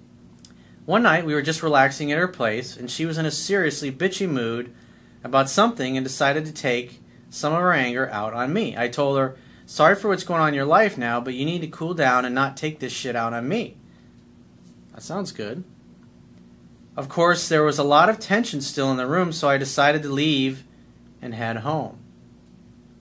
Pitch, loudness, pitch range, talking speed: 135 Hz, -22 LUFS, 120-155 Hz, 205 wpm